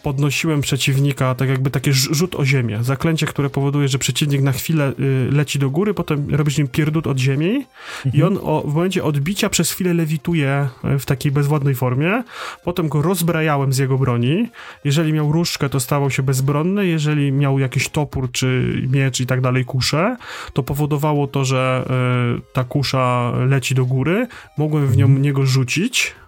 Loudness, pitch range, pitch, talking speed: -18 LUFS, 135-155 Hz, 145 Hz, 165 wpm